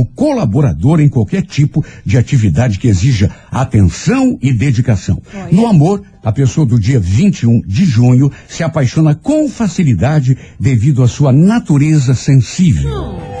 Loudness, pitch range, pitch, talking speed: -12 LUFS, 120-155 Hz, 135 Hz, 130 wpm